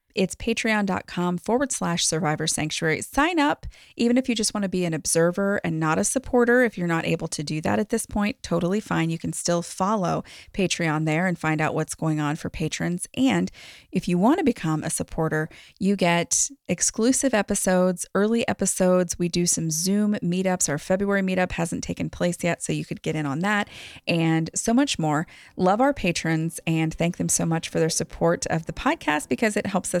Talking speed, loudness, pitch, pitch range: 205 wpm, -24 LUFS, 175 Hz, 160-210 Hz